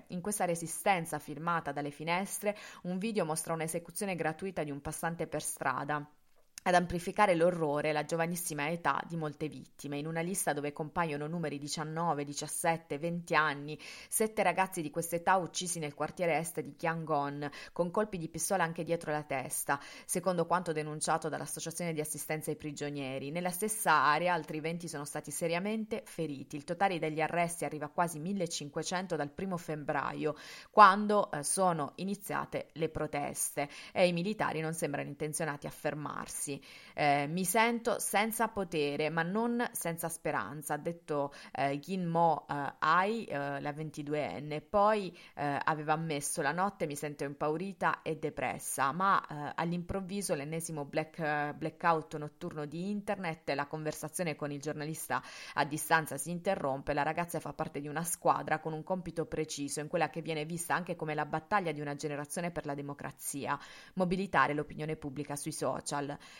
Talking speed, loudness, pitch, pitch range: 160 wpm, -34 LUFS, 160 Hz, 150-175 Hz